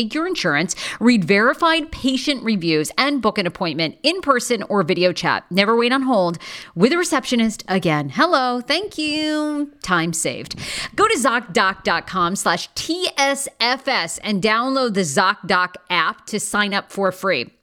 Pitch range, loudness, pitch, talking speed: 190-275 Hz, -19 LUFS, 225 Hz, 140 wpm